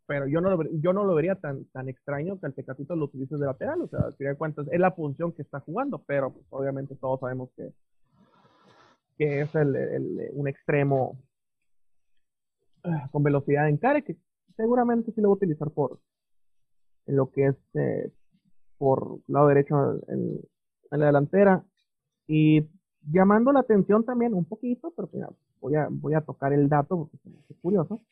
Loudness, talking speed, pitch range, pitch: -26 LUFS, 175 wpm, 140-190 Hz, 150 Hz